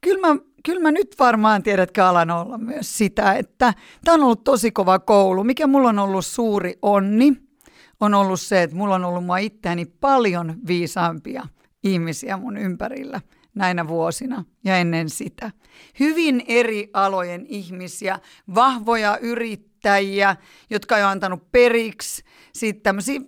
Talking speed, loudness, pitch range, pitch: 140 wpm, -20 LUFS, 185-245 Hz, 205 Hz